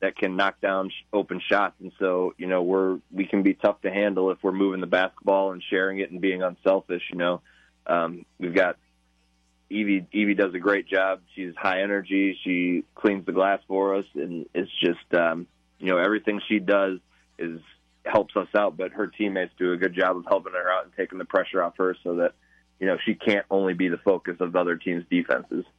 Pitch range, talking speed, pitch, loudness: 90-95 Hz, 215 wpm, 95 Hz, -25 LUFS